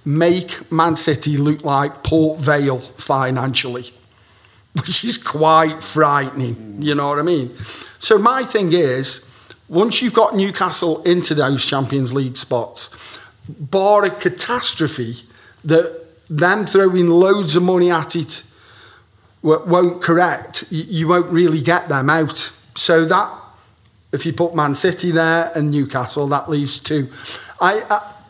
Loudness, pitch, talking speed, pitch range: -16 LUFS, 155 Hz, 135 wpm, 135-175 Hz